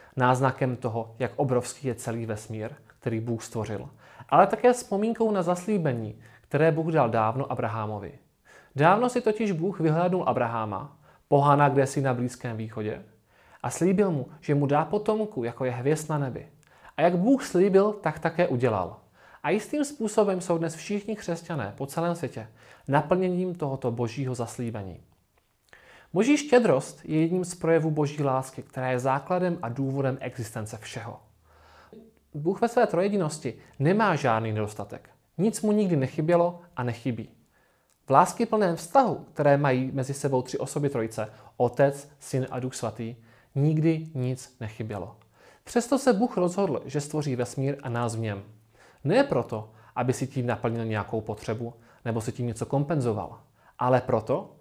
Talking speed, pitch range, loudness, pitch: 150 wpm, 115-170 Hz, -27 LUFS, 135 Hz